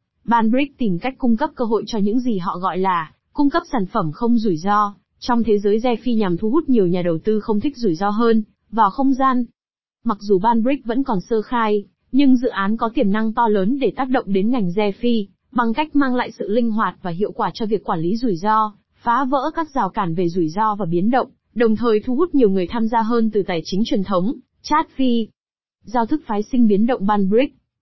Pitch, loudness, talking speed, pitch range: 225 Hz, -19 LUFS, 240 wpm, 205-250 Hz